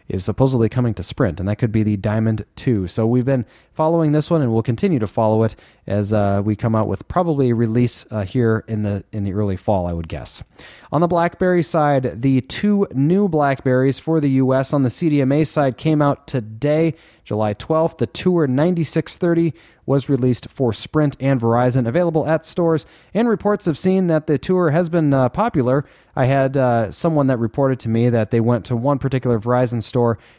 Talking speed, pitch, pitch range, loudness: 200 wpm, 130 Hz, 115-155 Hz, -19 LUFS